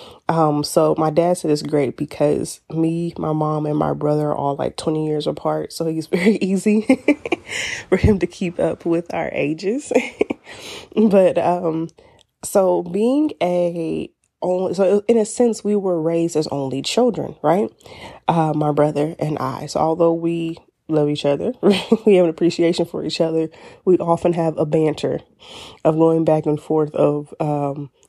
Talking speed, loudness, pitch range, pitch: 170 wpm, -19 LUFS, 155-185 Hz, 165 Hz